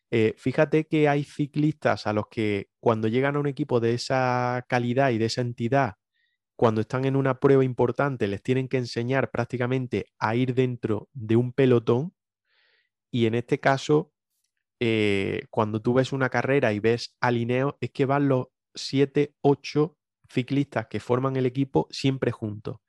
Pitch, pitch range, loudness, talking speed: 130 Hz, 115-140 Hz, -25 LUFS, 165 wpm